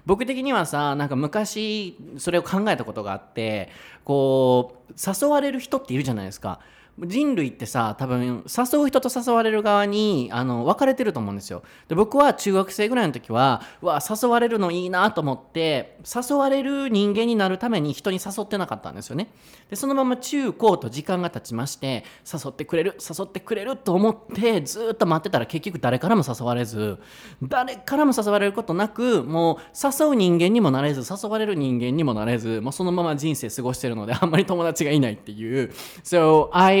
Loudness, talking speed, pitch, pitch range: -23 LUFS, 390 characters per minute, 180 Hz, 130-220 Hz